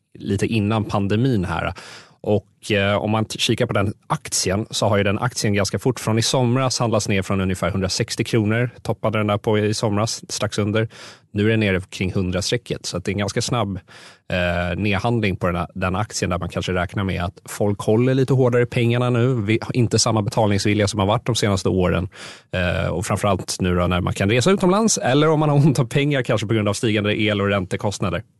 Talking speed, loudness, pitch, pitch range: 220 wpm, -20 LUFS, 105 Hz, 100-120 Hz